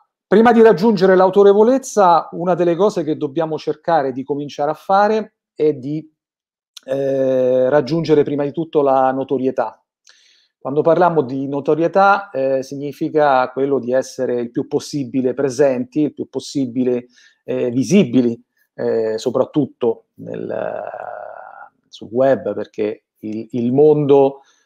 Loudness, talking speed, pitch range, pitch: -17 LUFS, 125 wpm, 130-170 Hz, 145 Hz